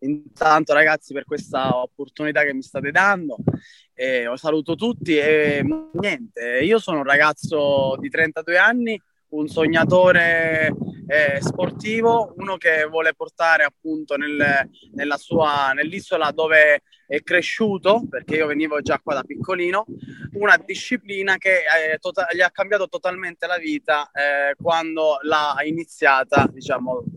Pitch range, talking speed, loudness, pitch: 150-185 Hz, 135 wpm, -19 LUFS, 160 Hz